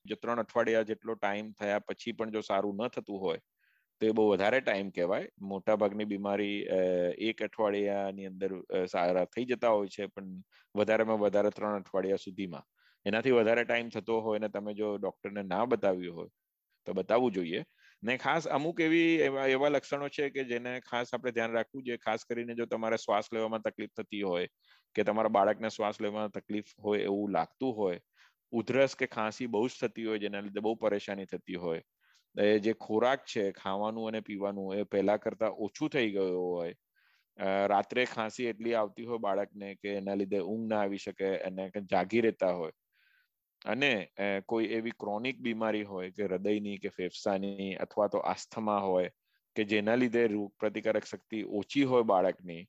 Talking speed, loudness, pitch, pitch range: 175 wpm, -32 LUFS, 105 Hz, 100-115 Hz